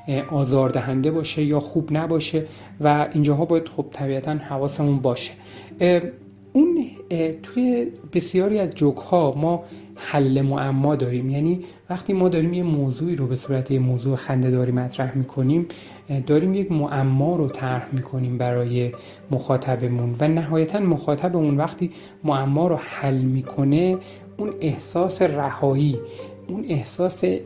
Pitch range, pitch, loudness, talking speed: 130-170 Hz, 145 Hz, -22 LUFS, 130 wpm